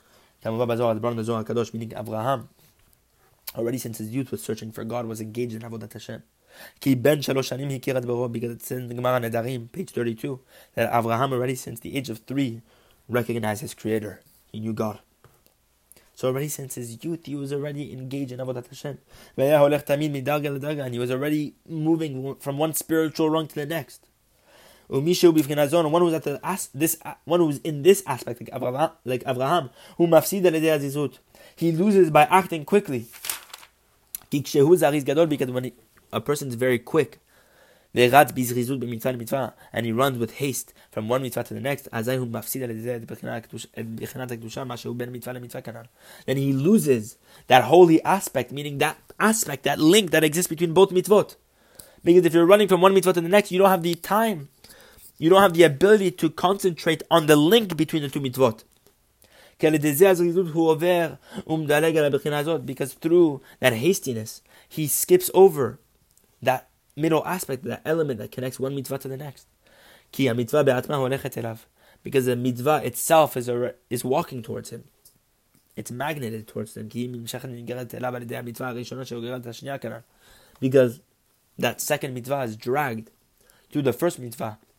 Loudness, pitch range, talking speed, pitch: -23 LUFS, 120-160 Hz, 125 wpm, 135 Hz